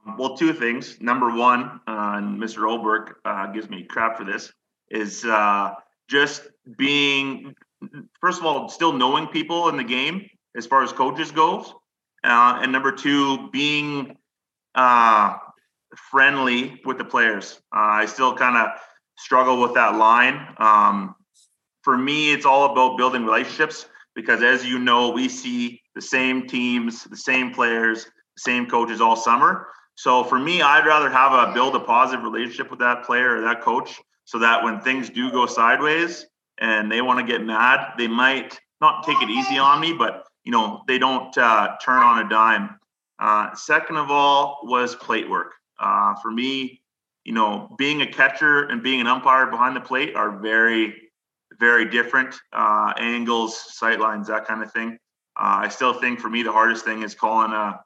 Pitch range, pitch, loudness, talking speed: 115-140 Hz, 125 Hz, -19 LUFS, 175 wpm